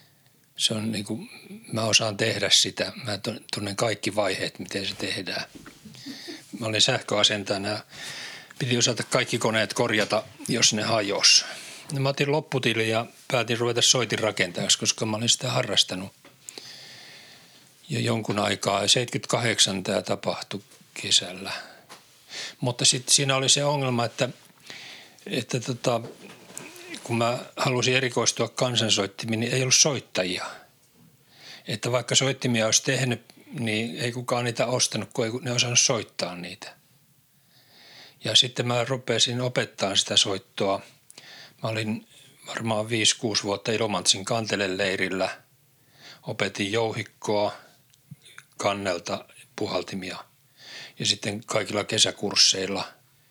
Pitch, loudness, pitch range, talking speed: 115 Hz, -24 LUFS, 105-130 Hz, 115 wpm